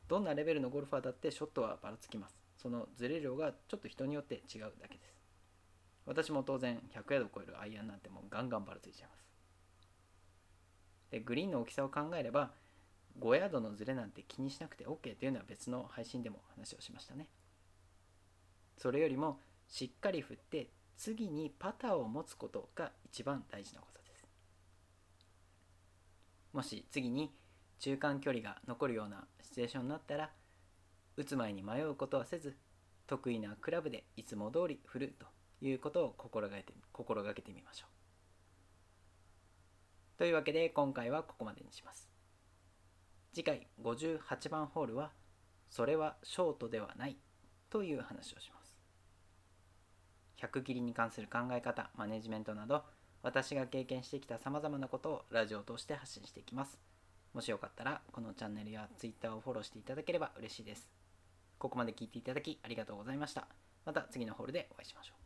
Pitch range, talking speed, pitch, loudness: 90-135 Hz, 360 characters per minute, 105 Hz, -42 LUFS